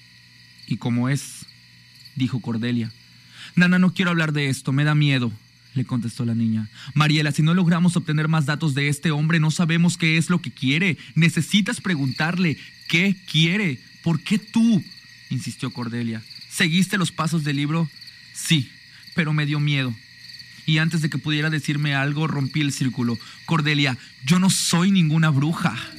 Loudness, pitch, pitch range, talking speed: -21 LUFS, 150 Hz, 125-165 Hz, 160 wpm